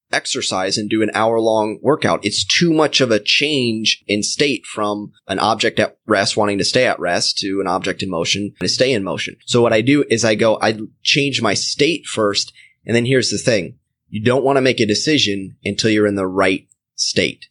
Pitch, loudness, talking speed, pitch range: 110 Hz, -17 LUFS, 220 wpm, 100-120 Hz